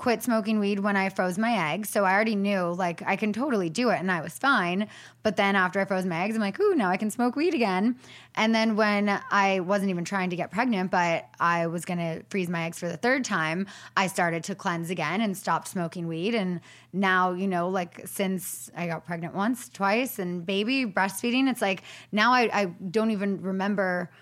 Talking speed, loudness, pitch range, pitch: 225 wpm, -26 LUFS, 180-220 Hz, 195 Hz